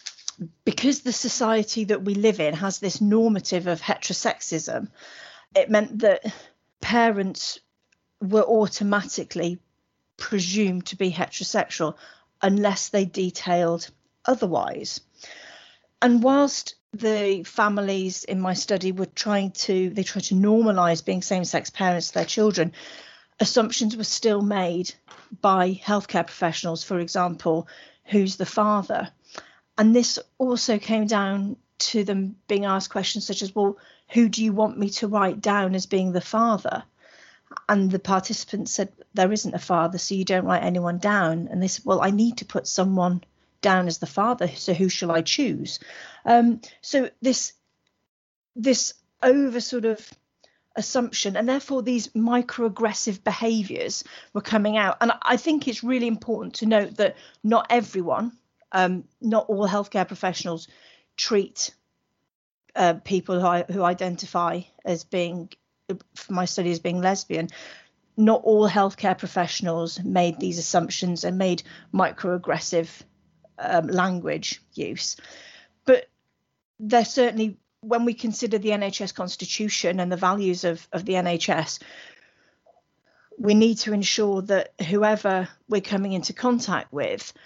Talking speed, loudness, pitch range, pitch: 140 wpm, -24 LUFS, 180-220 Hz, 200 Hz